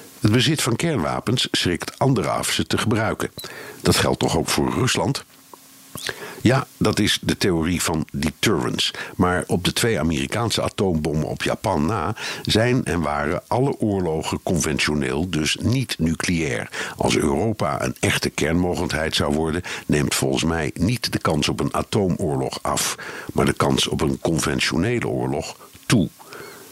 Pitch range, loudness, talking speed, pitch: 75-95 Hz, -21 LUFS, 150 wpm, 80 Hz